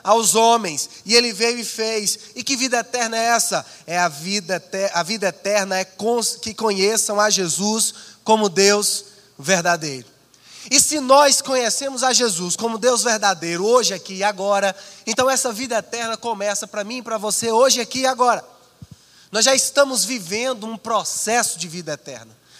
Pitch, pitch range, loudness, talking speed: 220 Hz, 195-235 Hz, -18 LUFS, 165 wpm